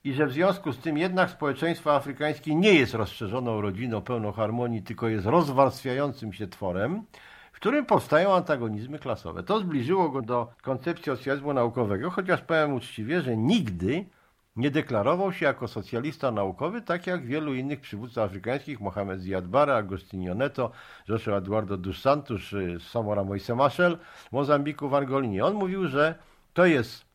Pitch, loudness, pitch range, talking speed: 135 Hz, -27 LUFS, 110-155 Hz, 150 wpm